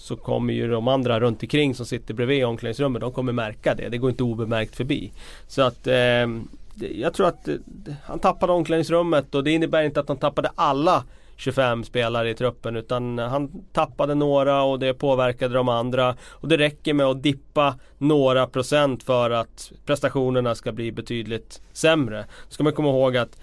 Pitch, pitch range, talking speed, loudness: 130 Hz, 120-145 Hz, 180 wpm, -23 LUFS